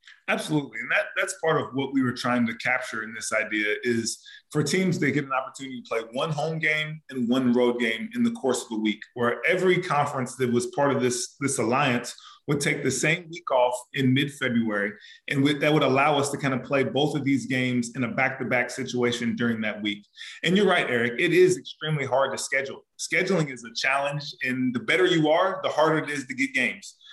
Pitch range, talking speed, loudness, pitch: 120-155 Hz, 230 wpm, -25 LUFS, 135 Hz